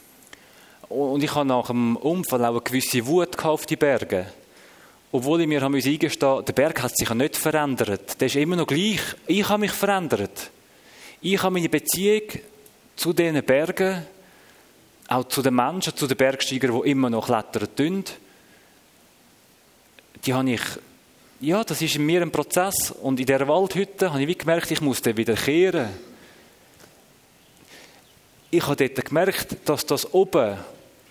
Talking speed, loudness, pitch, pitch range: 155 wpm, -23 LUFS, 145 Hz, 130-175 Hz